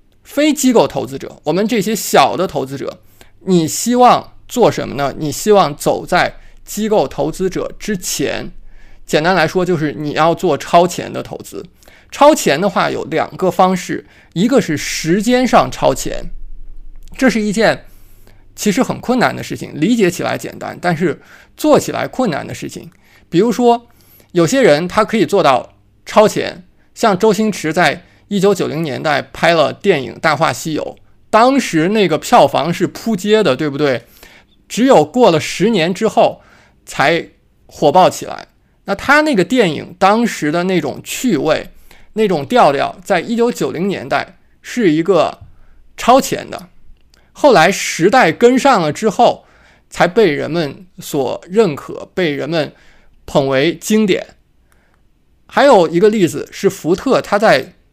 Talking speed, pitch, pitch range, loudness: 225 characters per minute, 190 Hz, 160-225 Hz, -14 LUFS